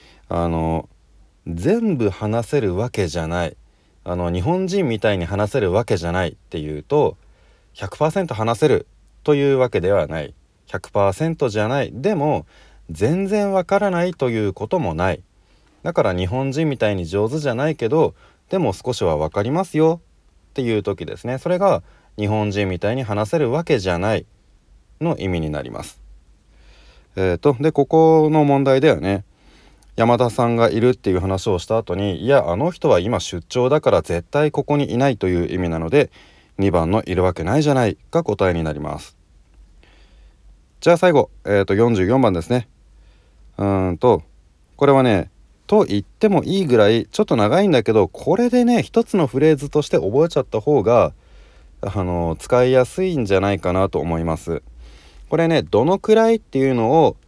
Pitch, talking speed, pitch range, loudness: 105 Hz, 325 characters per minute, 85-145 Hz, -19 LUFS